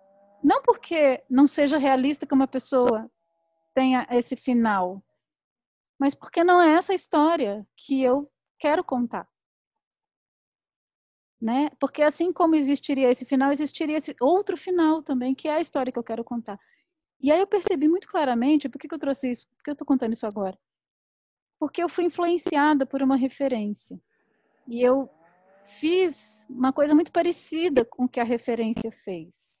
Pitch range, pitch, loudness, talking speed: 240-315 Hz, 275 Hz, -24 LUFS, 160 wpm